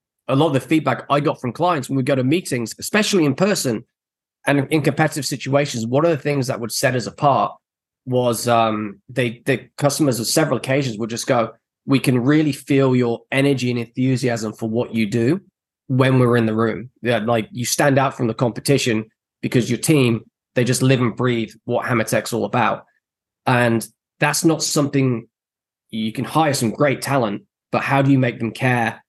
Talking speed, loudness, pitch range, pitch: 195 wpm, -19 LUFS, 115-140 Hz, 130 Hz